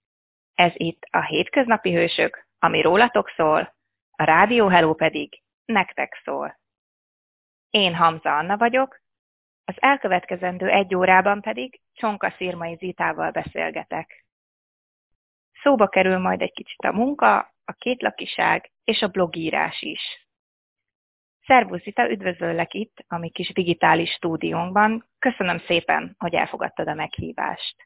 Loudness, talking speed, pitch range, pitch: -21 LUFS, 120 wpm, 170-220 Hz, 185 Hz